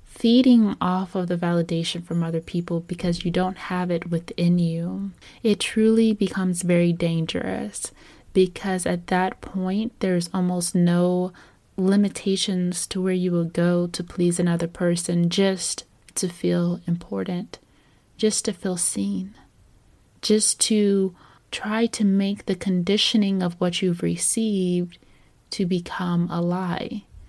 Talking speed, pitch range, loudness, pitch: 130 wpm, 170-195 Hz, -23 LUFS, 180 Hz